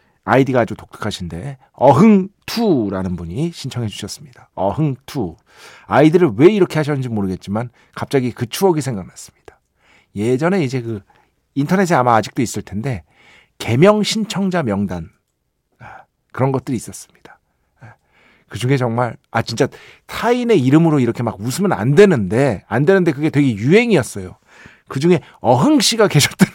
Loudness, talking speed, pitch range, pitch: -16 LUFS, 330 characters per minute, 115-180 Hz, 135 Hz